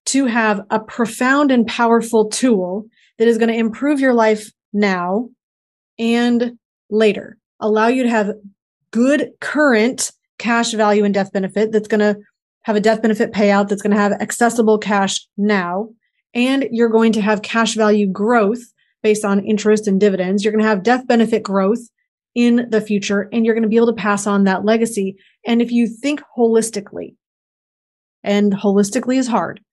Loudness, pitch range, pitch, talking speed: -16 LUFS, 205-235 Hz, 220 Hz, 175 wpm